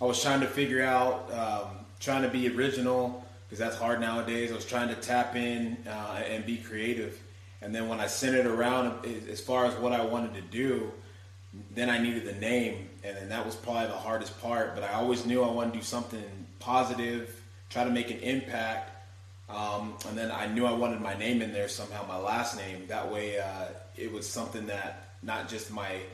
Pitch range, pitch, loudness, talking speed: 105-120 Hz, 115 Hz, -32 LUFS, 215 wpm